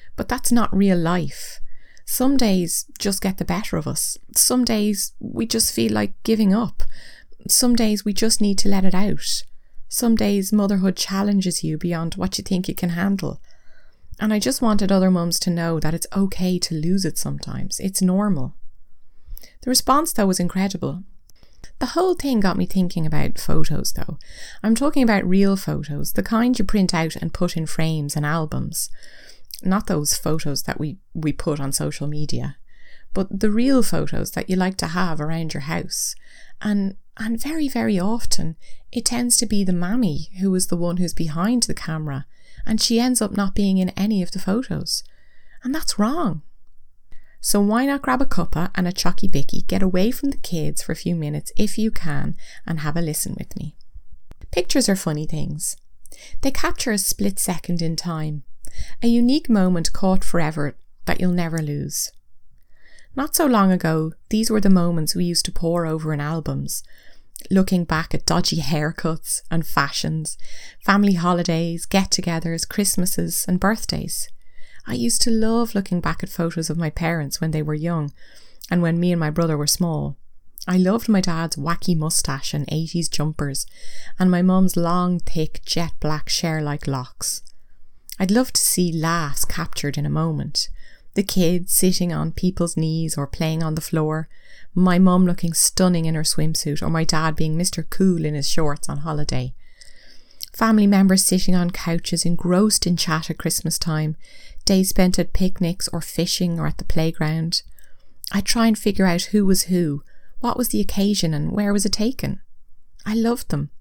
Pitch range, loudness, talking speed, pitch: 160-200 Hz, -21 LUFS, 180 wpm, 180 Hz